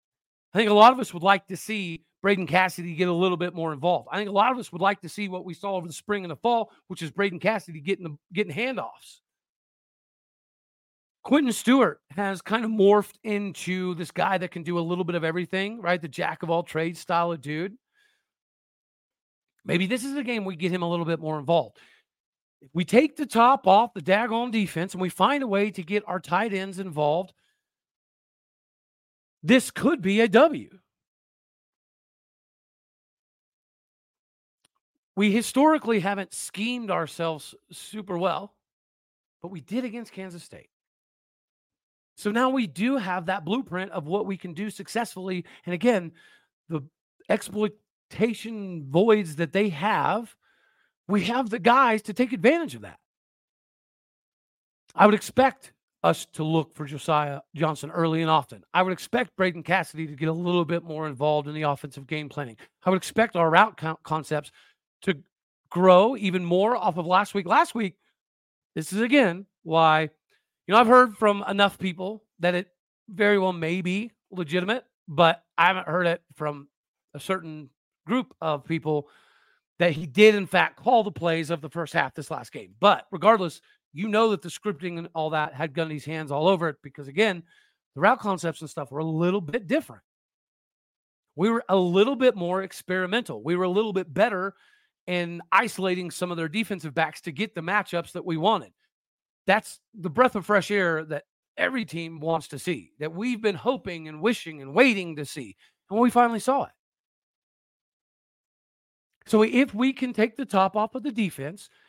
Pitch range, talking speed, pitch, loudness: 165-215 Hz, 180 wpm, 185 Hz, -25 LUFS